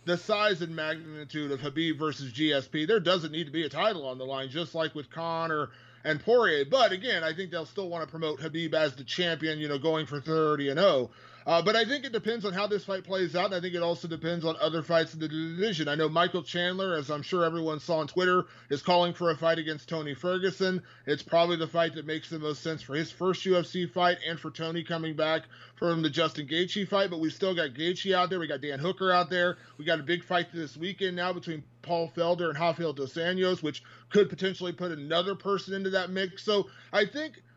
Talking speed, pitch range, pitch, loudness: 240 wpm, 155-180 Hz, 165 Hz, -29 LUFS